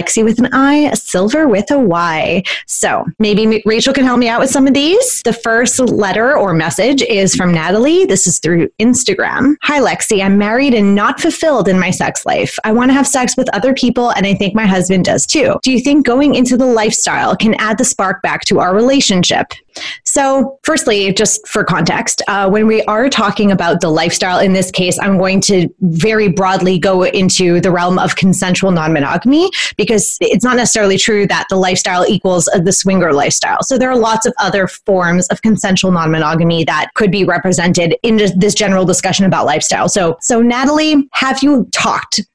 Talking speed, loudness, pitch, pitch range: 195 wpm, -11 LUFS, 210 Hz, 185-245 Hz